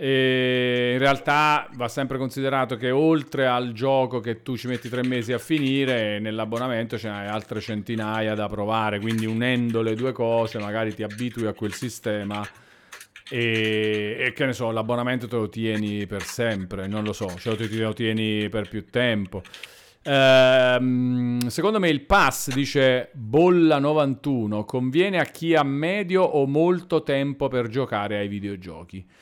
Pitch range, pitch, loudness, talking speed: 110-135 Hz, 120 Hz, -23 LUFS, 160 wpm